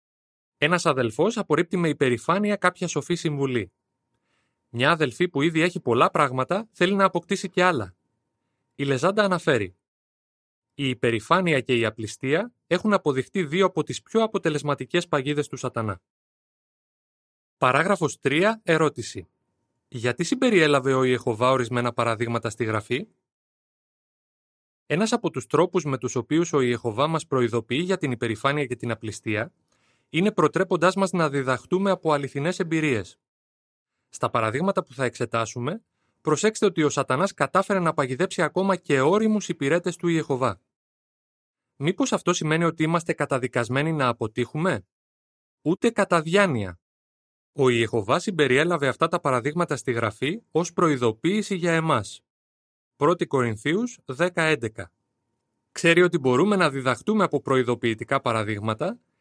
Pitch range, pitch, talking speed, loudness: 120-175 Hz, 145 Hz, 130 wpm, -24 LUFS